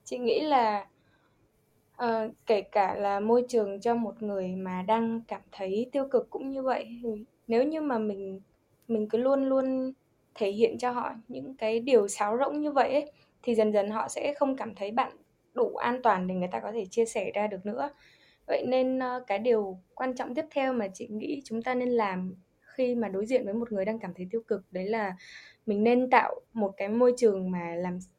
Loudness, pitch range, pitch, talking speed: -29 LUFS, 205-255 Hz, 225 Hz, 220 wpm